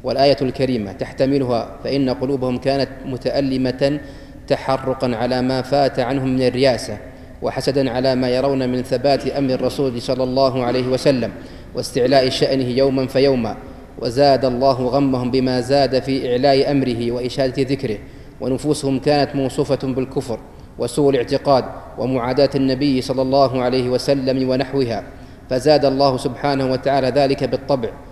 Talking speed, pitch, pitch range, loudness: 125 wpm, 130 Hz, 130-140 Hz, -18 LUFS